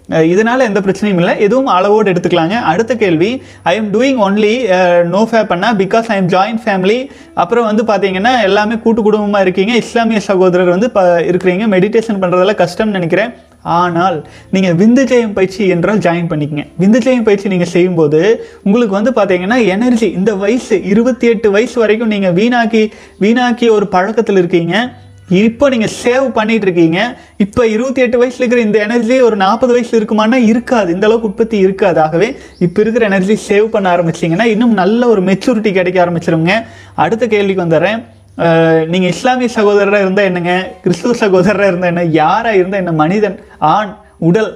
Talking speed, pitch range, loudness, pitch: 155 wpm, 180-230 Hz, -11 LUFS, 205 Hz